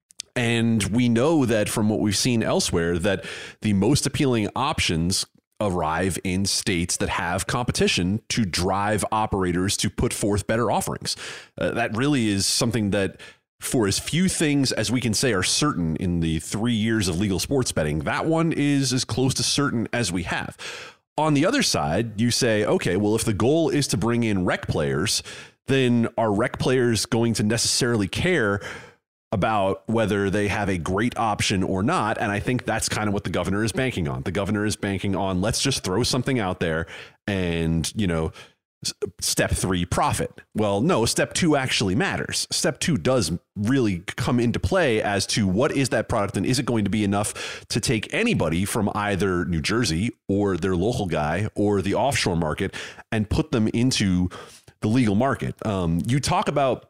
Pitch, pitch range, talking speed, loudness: 105 Hz, 95-120 Hz, 185 wpm, -23 LUFS